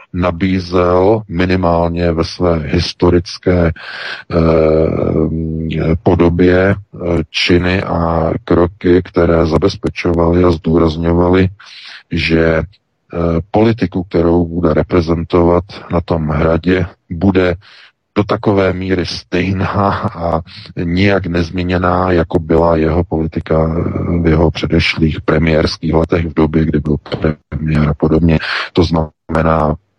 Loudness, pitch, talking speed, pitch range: -14 LUFS, 85 Hz, 100 wpm, 80-90 Hz